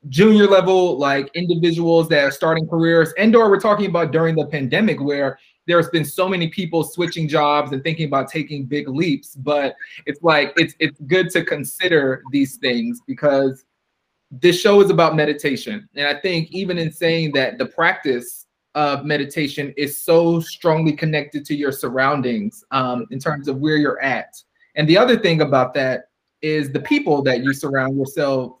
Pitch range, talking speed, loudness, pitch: 140-170 Hz, 175 wpm, -18 LUFS, 155 Hz